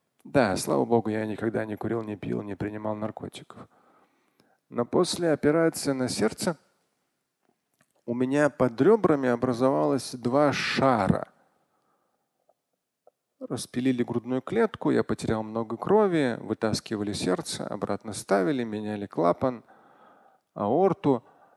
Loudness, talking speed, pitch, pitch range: -26 LUFS, 105 wpm, 120 Hz, 110-145 Hz